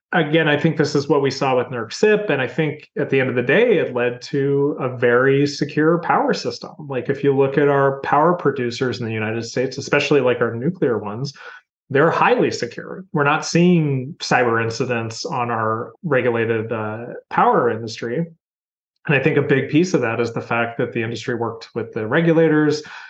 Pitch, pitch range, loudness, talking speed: 135 Hz, 120-150 Hz, -19 LUFS, 200 wpm